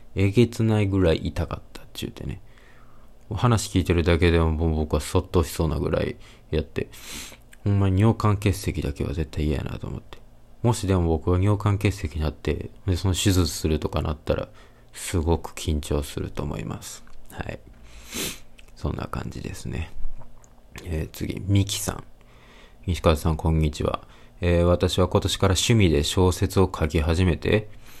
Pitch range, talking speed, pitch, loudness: 75-100 Hz, 315 characters per minute, 90 Hz, -24 LUFS